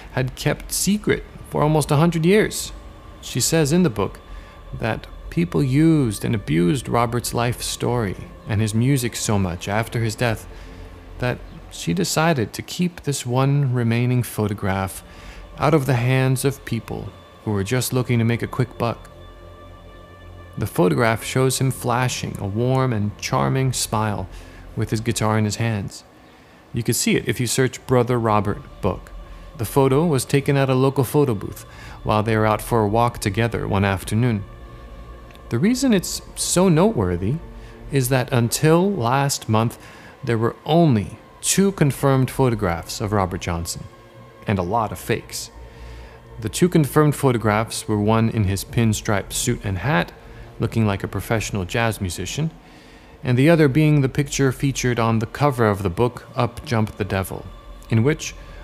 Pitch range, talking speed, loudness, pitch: 100-135 Hz, 165 wpm, -21 LUFS, 115 Hz